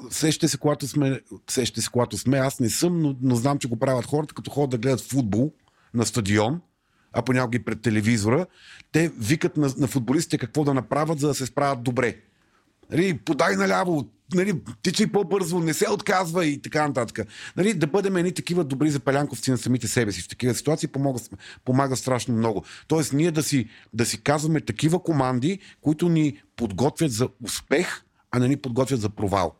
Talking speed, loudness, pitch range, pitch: 190 wpm, -24 LUFS, 120-155 Hz, 135 Hz